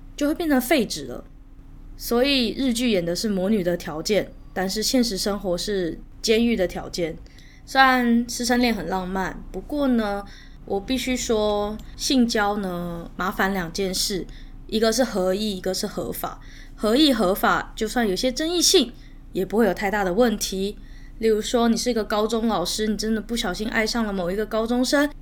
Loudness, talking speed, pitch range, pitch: -23 LUFS, 260 characters per minute, 190-240 Hz, 215 Hz